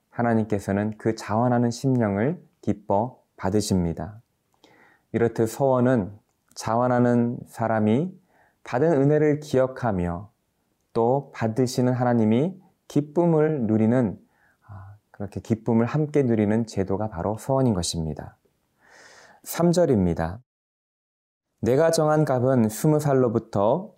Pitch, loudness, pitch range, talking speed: 115 Hz, -23 LUFS, 105-130 Hz, 245 characters per minute